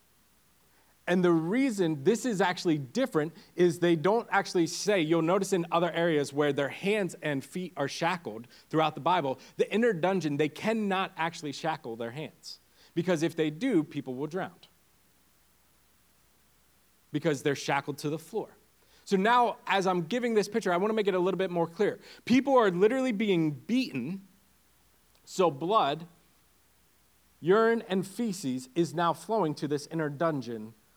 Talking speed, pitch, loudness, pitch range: 160 wpm, 170 Hz, -29 LUFS, 150-195 Hz